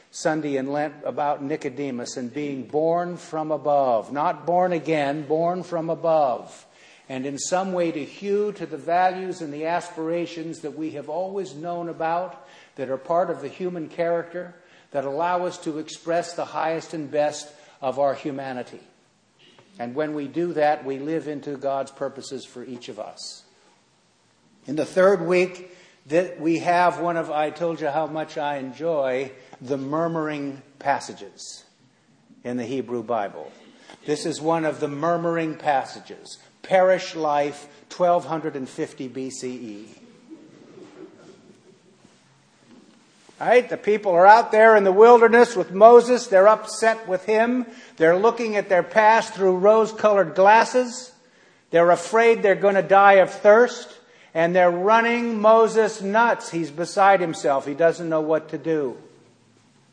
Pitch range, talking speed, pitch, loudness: 150-185 Hz, 150 wpm, 165 Hz, -21 LUFS